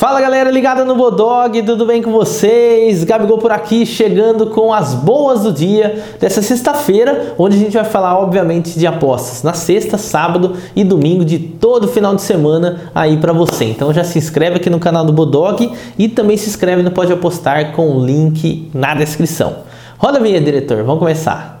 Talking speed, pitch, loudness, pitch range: 190 wpm, 185 Hz, -12 LUFS, 160-220 Hz